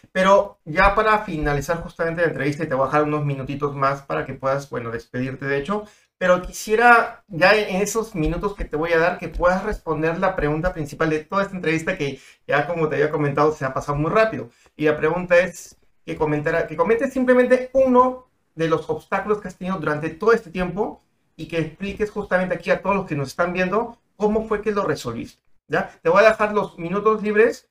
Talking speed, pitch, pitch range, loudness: 210 wpm, 175 Hz, 155-205 Hz, -21 LUFS